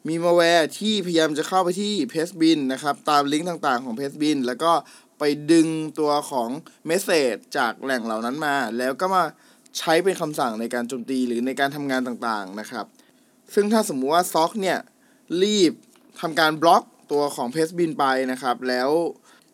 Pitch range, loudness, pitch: 130-175 Hz, -22 LUFS, 155 Hz